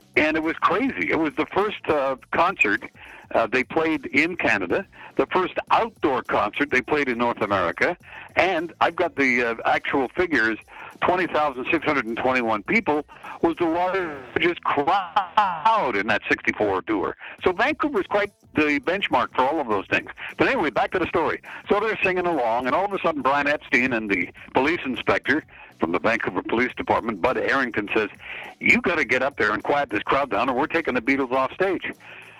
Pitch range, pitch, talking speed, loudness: 125-180 Hz, 150 Hz, 190 wpm, -22 LUFS